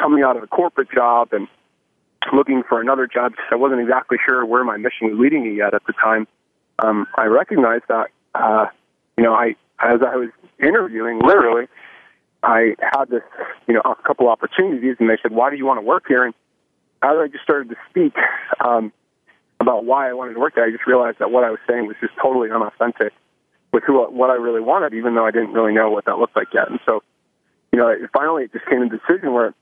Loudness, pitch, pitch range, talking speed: -18 LUFS, 120 Hz, 115-130 Hz, 225 wpm